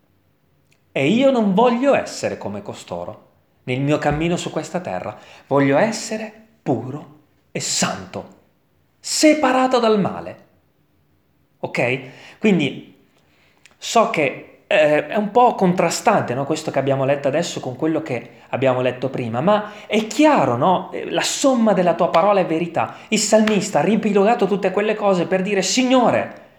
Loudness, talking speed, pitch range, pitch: -18 LUFS, 140 wpm, 150-220 Hz, 190 Hz